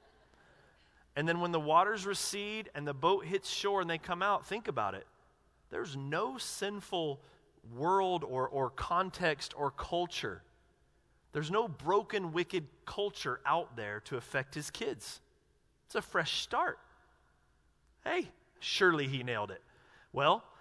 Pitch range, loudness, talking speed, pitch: 135-195 Hz, -35 LUFS, 140 wpm, 165 Hz